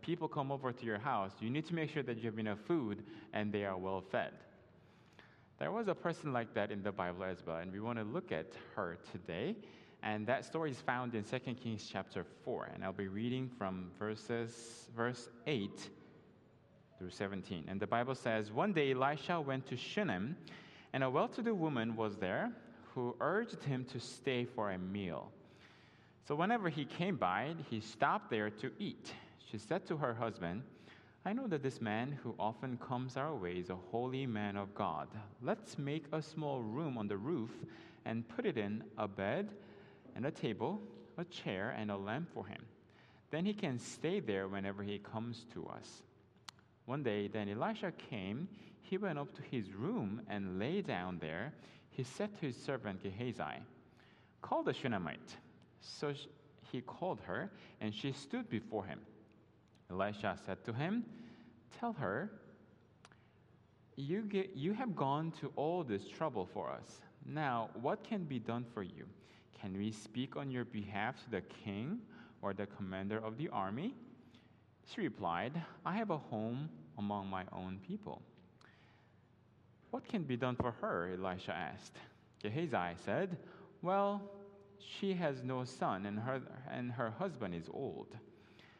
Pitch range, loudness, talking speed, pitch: 105-155 Hz, -41 LUFS, 170 wpm, 120 Hz